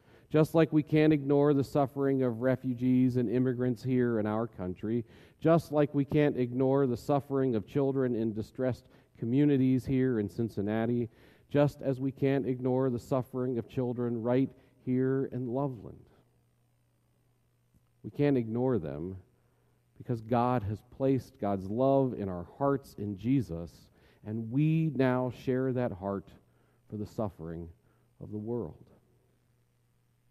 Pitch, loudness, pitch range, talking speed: 125 Hz, -30 LUFS, 110-135 Hz, 140 wpm